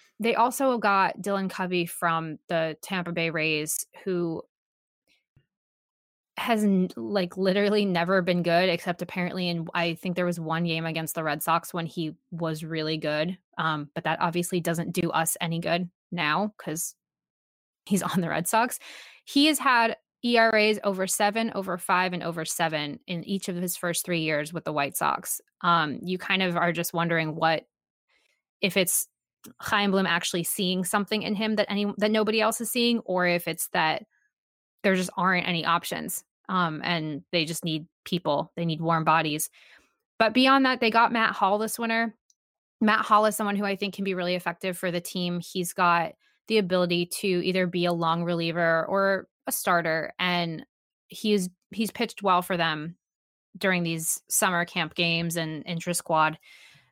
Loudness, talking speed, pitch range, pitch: -26 LUFS, 175 wpm, 165-200 Hz, 180 Hz